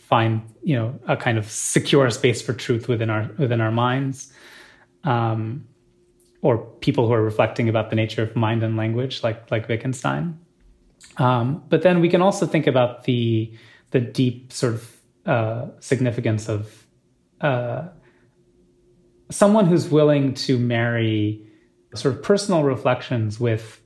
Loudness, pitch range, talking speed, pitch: -21 LUFS, 115-140 Hz, 145 wpm, 120 Hz